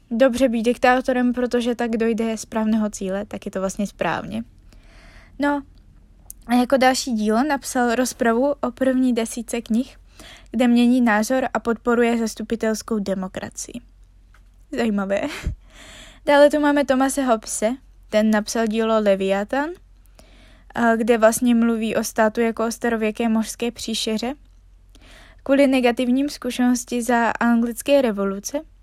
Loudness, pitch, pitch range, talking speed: -20 LUFS, 235 Hz, 220-255 Hz, 120 wpm